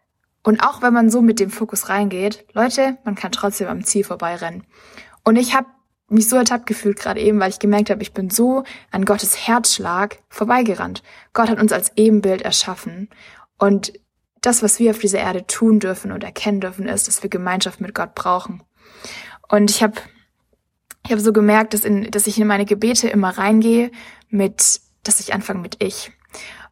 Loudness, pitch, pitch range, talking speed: -17 LUFS, 210 Hz, 200-225 Hz, 190 wpm